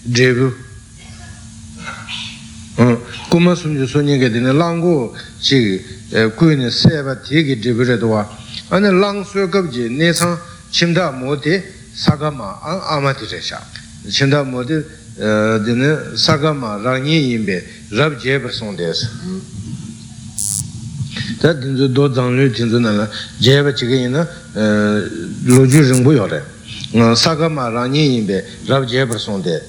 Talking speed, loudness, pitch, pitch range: 90 wpm, -15 LUFS, 130 Hz, 115-150 Hz